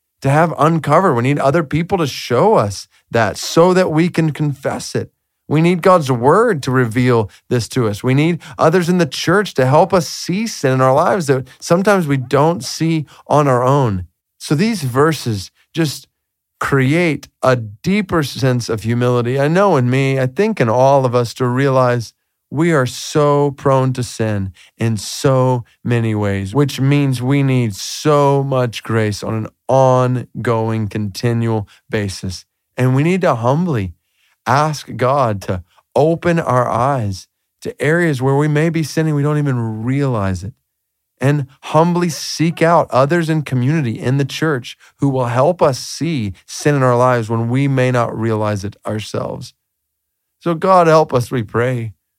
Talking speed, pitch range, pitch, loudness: 170 wpm, 115-155 Hz, 130 Hz, -16 LUFS